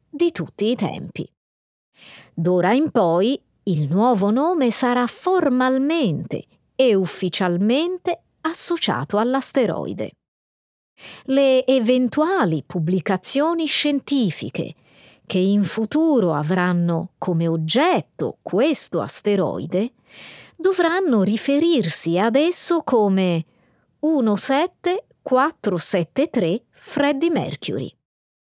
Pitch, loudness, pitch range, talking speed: 240 Hz, -20 LUFS, 185-290 Hz, 75 wpm